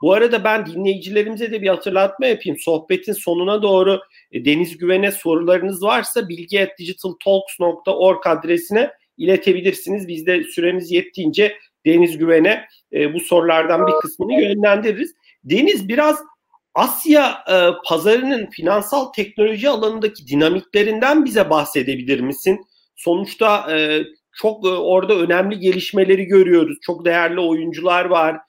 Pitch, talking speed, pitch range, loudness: 185 Hz, 105 wpm, 170-210 Hz, -17 LUFS